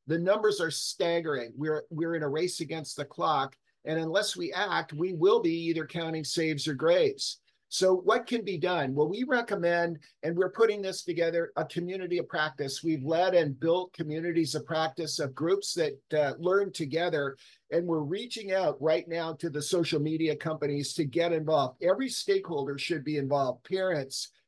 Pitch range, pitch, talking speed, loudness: 155-185 Hz, 165 Hz, 180 wpm, -29 LUFS